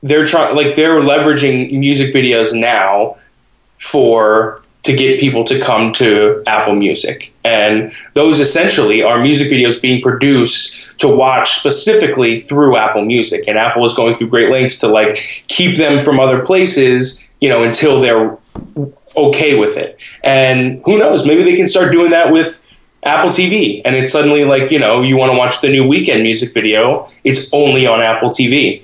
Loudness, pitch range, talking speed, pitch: -10 LUFS, 115-145 Hz, 175 wpm, 135 Hz